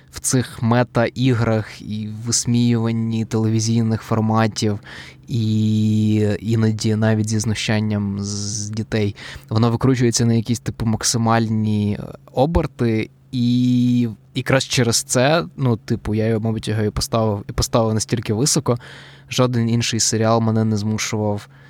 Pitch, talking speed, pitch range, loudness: 115 Hz, 125 wpm, 110-125 Hz, -19 LUFS